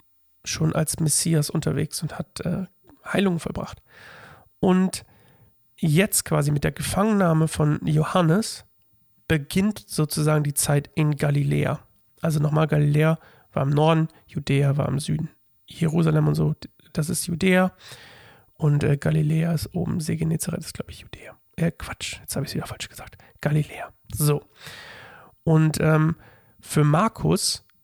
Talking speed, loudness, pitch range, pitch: 140 wpm, -23 LUFS, 145-165 Hz, 155 Hz